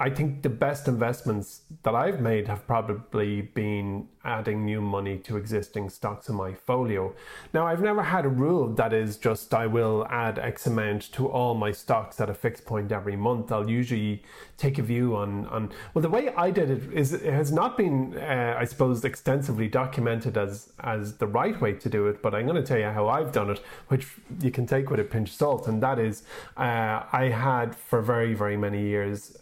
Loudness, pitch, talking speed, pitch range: -27 LUFS, 115 Hz, 215 wpm, 105-135 Hz